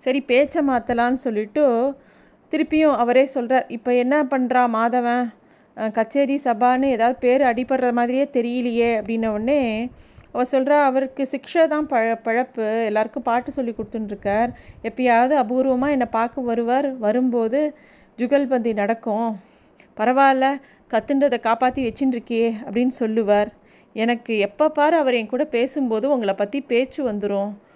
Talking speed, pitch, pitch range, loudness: 120 wpm, 245 Hz, 230-270 Hz, -20 LUFS